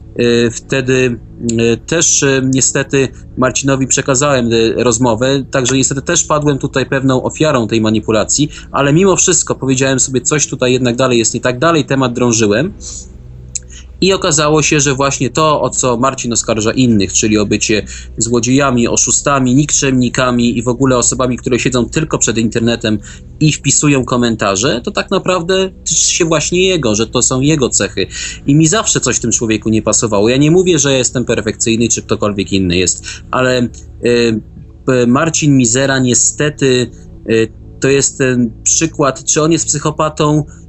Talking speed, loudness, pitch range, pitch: 155 wpm, -12 LUFS, 115-140 Hz, 125 Hz